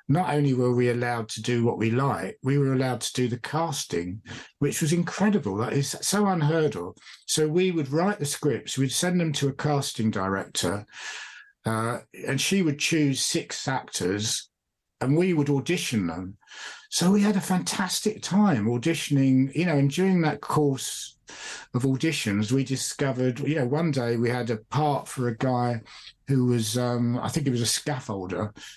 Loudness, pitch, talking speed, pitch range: -25 LUFS, 135 Hz, 185 wpm, 120-155 Hz